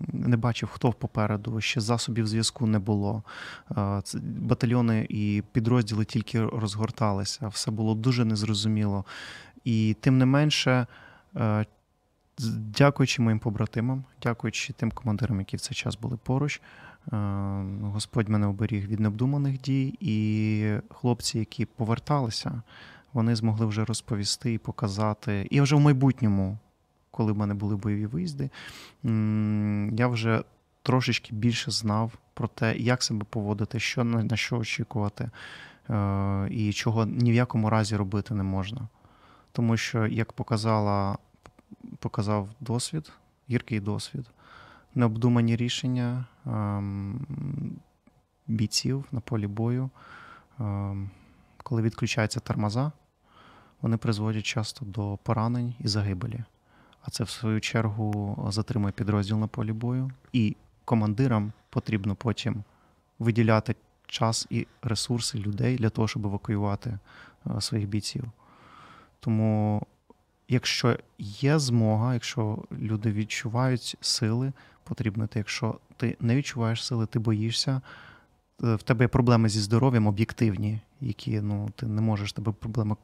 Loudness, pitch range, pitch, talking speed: -28 LUFS, 105-120 Hz, 110 Hz, 120 wpm